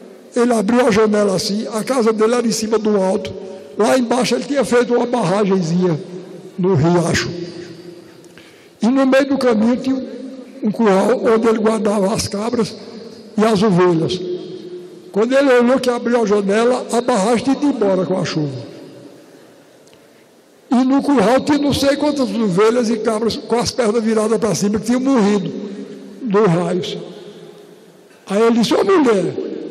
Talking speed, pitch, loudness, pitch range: 160 wpm, 220 Hz, -16 LUFS, 195-245 Hz